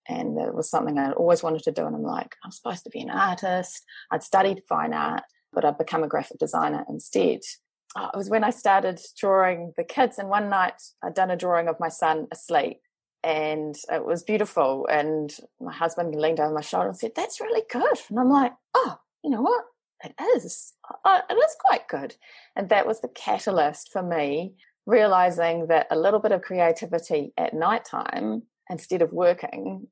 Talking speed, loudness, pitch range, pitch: 195 wpm, -25 LUFS, 165-235 Hz, 185 Hz